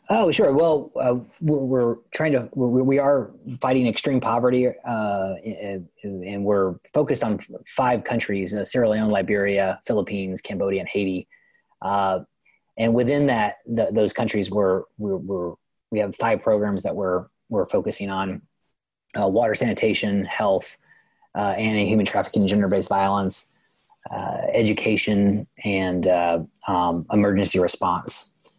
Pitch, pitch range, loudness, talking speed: 100 Hz, 95-115 Hz, -22 LUFS, 140 wpm